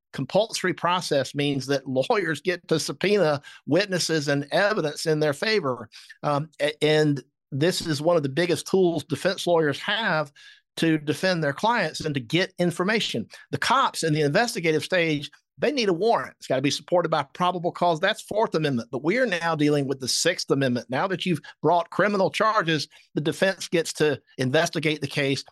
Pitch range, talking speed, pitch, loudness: 145-180 Hz, 180 wpm, 160 Hz, -24 LUFS